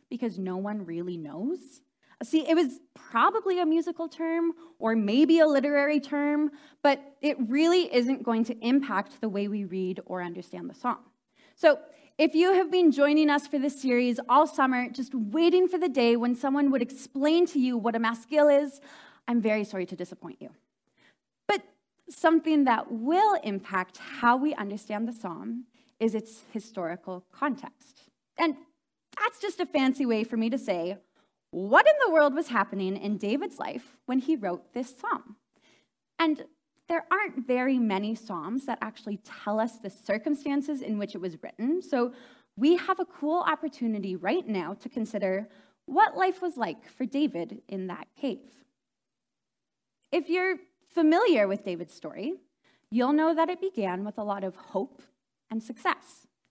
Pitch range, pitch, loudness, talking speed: 215-310 Hz, 265 Hz, -27 LUFS, 165 wpm